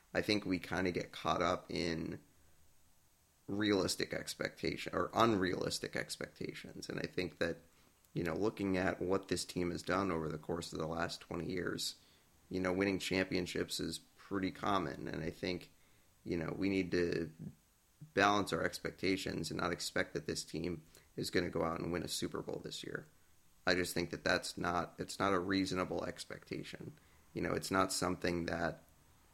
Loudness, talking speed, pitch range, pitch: -38 LUFS, 180 wpm, 85-95 Hz, 90 Hz